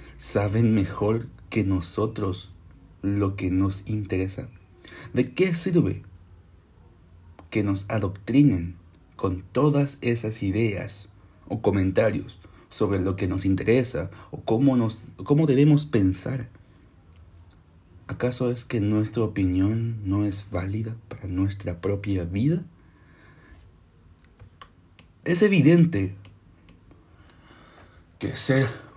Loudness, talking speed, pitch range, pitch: -25 LUFS, 100 wpm, 90-115 Hz, 100 Hz